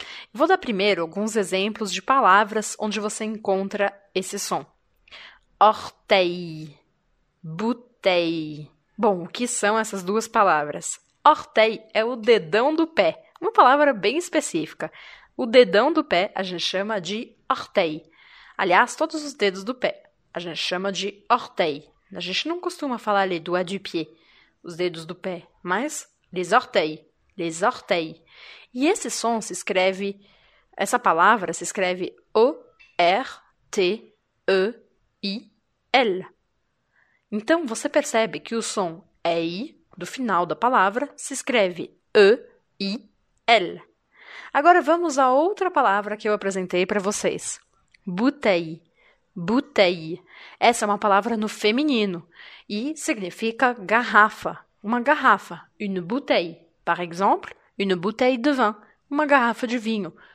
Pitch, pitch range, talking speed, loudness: 210 Hz, 185-255 Hz, 125 wpm, -22 LUFS